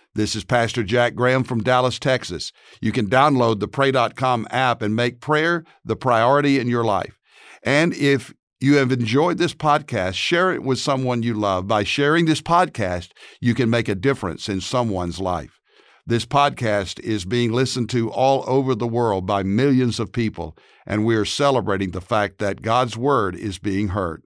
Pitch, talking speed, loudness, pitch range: 120 Hz, 180 wpm, -20 LUFS, 105-135 Hz